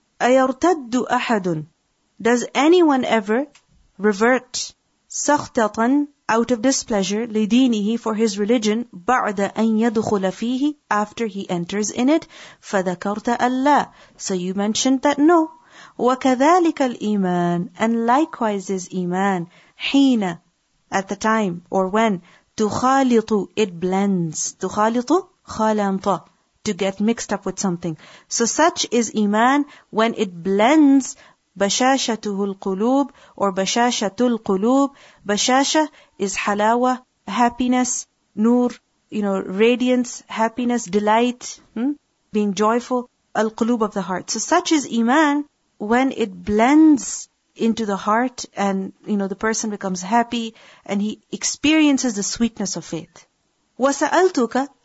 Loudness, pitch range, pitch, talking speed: -20 LUFS, 200-255 Hz, 225 Hz, 115 wpm